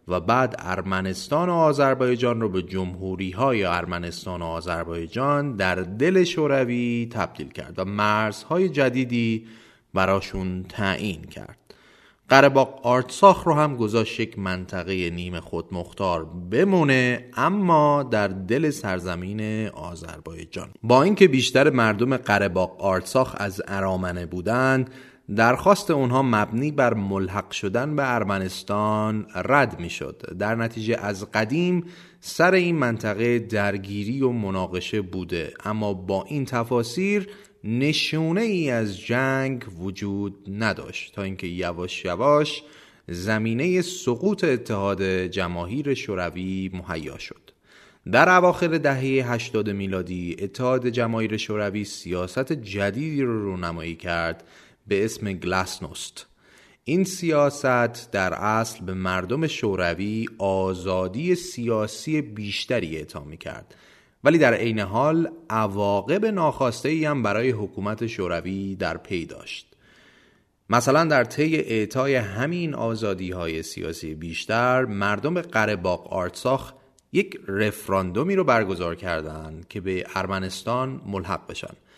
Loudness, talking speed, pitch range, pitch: -23 LUFS, 115 wpm, 95-130 Hz, 110 Hz